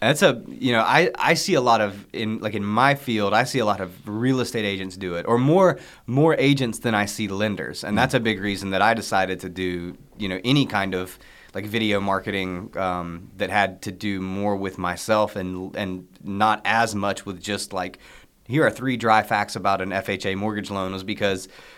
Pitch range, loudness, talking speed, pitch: 95-110 Hz, -23 LUFS, 220 wpm, 100 Hz